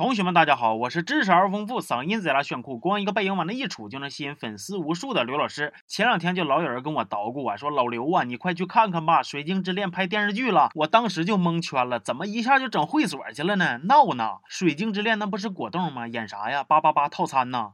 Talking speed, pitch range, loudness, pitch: 380 characters per minute, 145-210 Hz, -24 LUFS, 175 Hz